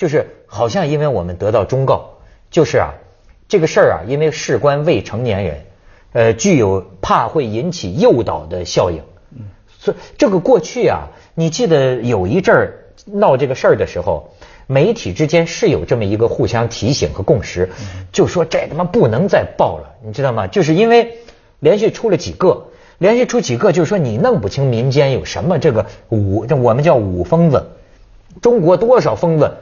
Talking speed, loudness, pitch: 275 characters per minute, -15 LUFS, 140 Hz